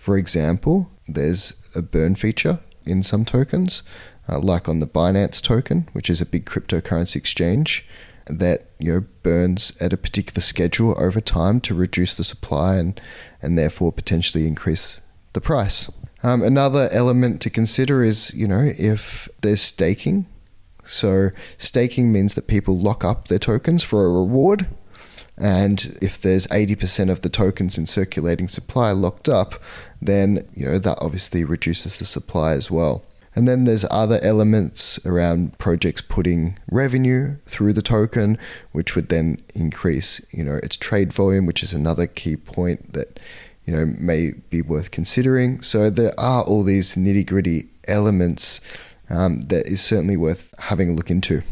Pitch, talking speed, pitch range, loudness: 95 Hz, 160 wpm, 85-110 Hz, -20 LUFS